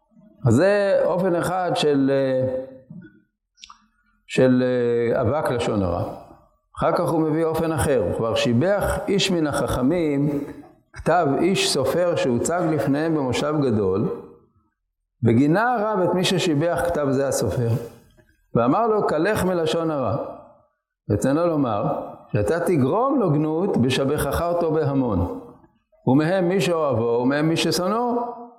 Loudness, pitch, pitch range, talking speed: -21 LUFS, 150 Hz, 125-175 Hz, 120 wpm